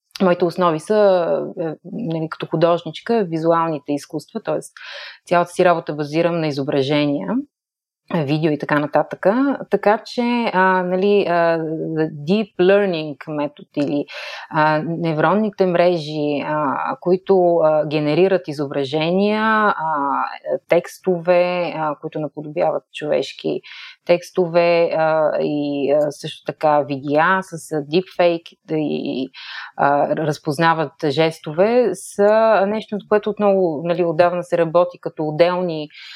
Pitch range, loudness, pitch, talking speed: 155-185 Hz, -19 LUFS, 170 Hz, 110 wpm